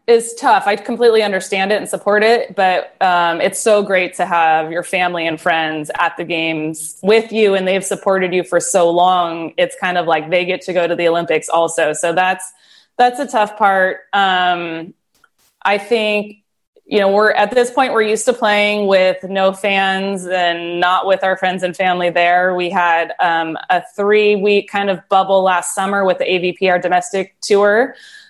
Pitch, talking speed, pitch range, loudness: 190 Hz, 195 wpm, 175-205 Hz, -15 LUFS